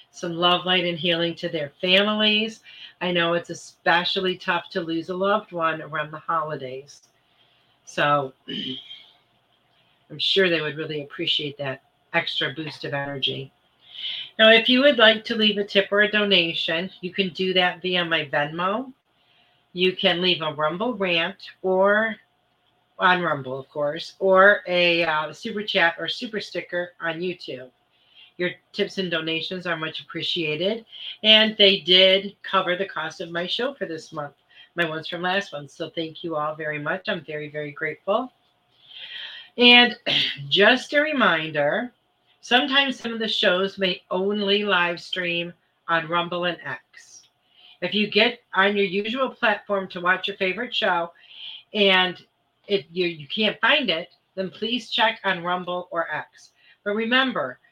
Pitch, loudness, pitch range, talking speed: 180 Hz, -22 LUFS, 160-200 Hz, 160 wpm